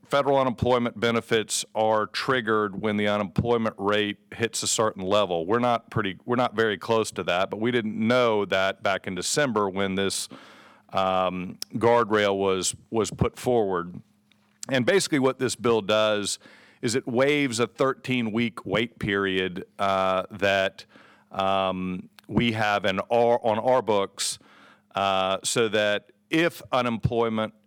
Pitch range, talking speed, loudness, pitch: 100-120 Hz, 140 wpm, -25 LUFS, 110 Hz